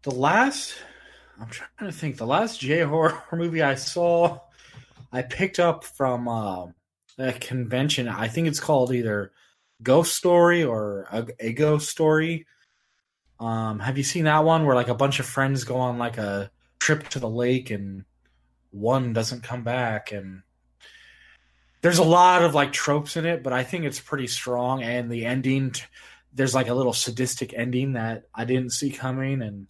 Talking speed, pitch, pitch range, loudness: 170 wpm, 130 Hz, 115-155 Hz, -24 LUFS